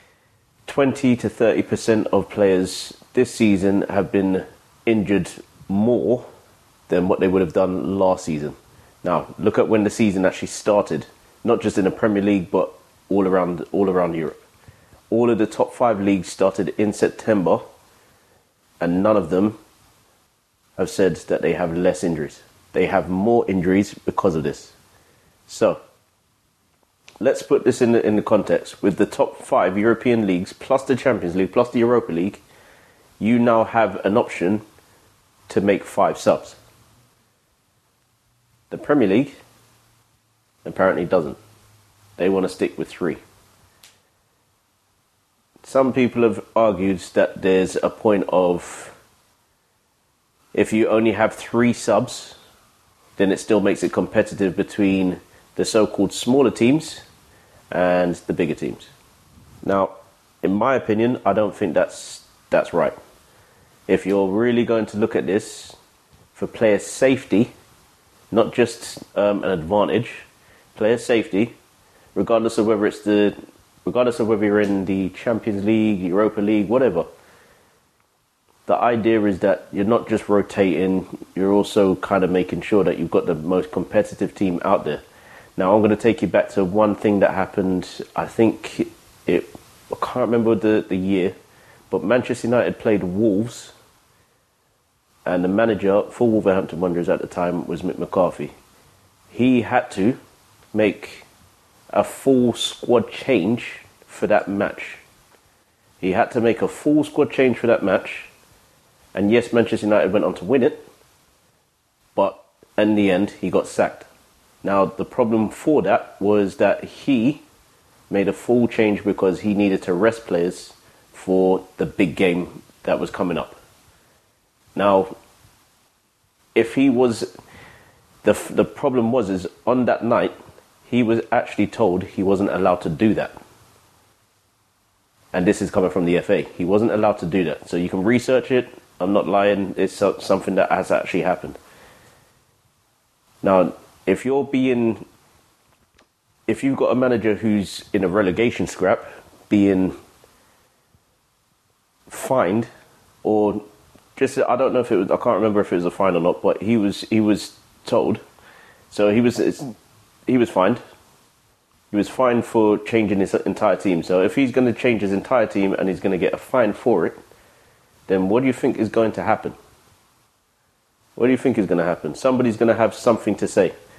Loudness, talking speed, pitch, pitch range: -20 LUFS, 155 wpm, 105 Hz, 95-115 Hz